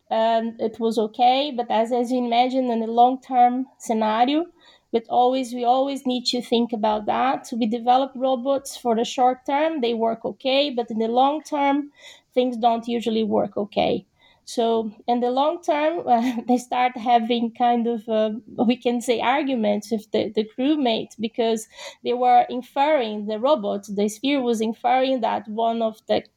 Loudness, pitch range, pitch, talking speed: -22 LUFS, 230-260 Hz, 245 Hz, 175 wpm